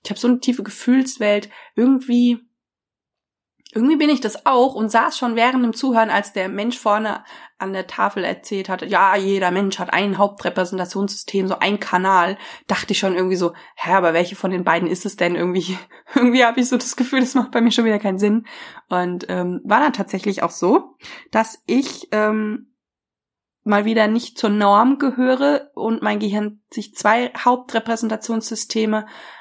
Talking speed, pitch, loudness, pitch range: 180 wpm, 215 Hz, -19 LUFS, 195-245 Hz